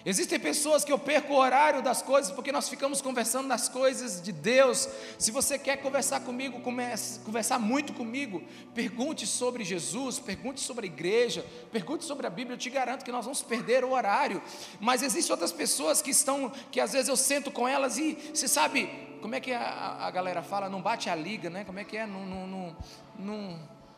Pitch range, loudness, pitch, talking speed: 225-275 Hz, -29 LUFS, 255 Hz, 205 wpm